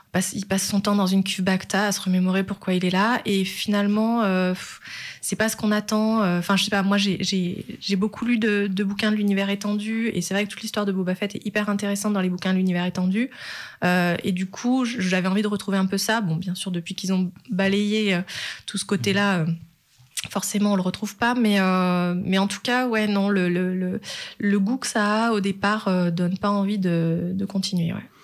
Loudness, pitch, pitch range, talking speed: -23 LUFS, 195 Hz, 185-210 Hz, 235 wpm